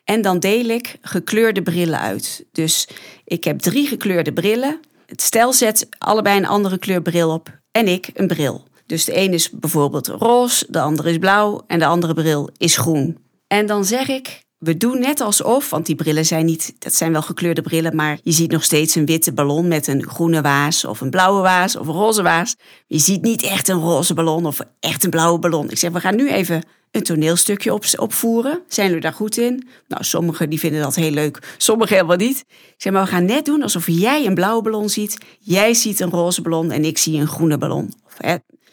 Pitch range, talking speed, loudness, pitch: 160-215 Hz, 220 wpm, -17 LUFS, 175 Hz